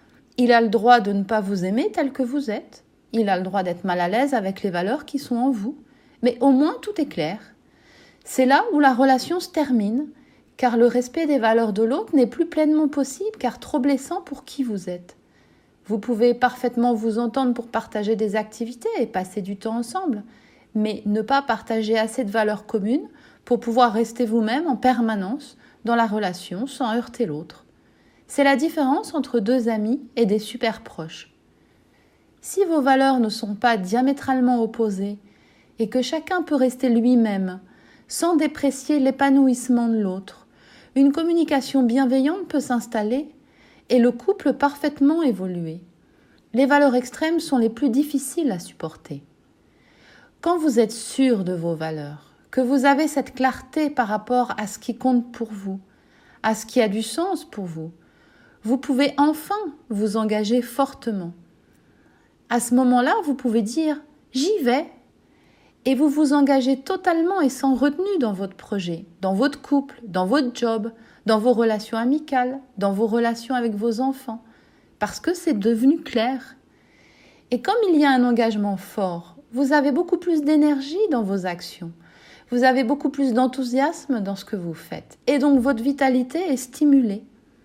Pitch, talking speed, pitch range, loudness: 250 Hz, 170 wpm, 220-280 Hz, -22 LUFS